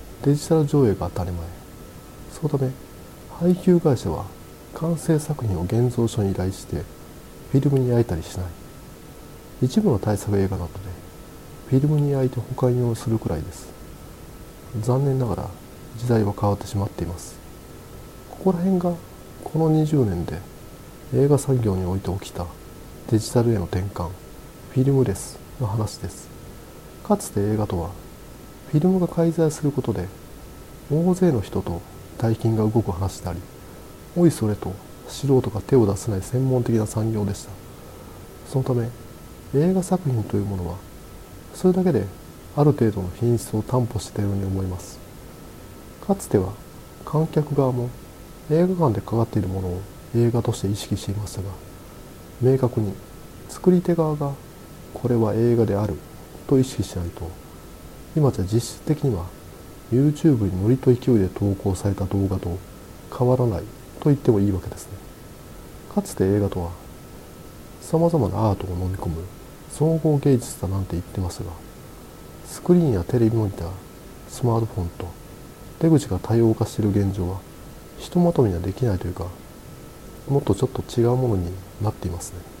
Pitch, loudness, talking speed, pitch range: 105 Hz, -23 LUFS, 315 characters per minute, 90-130 Hz